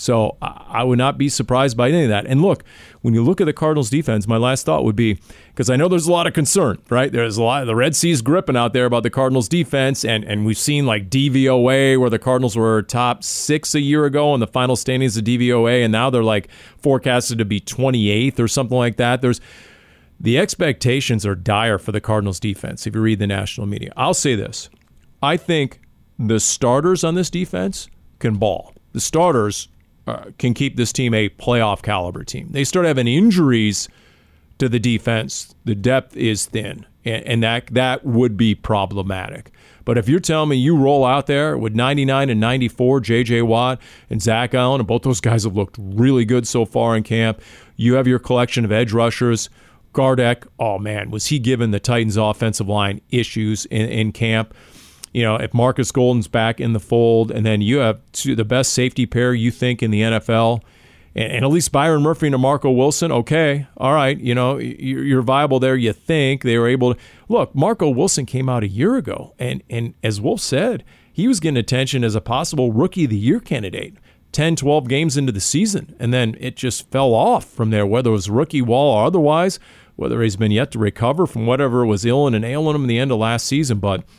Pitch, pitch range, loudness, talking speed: 125 Hz, 110-135 Hz, -18 LUFS, 215 wpm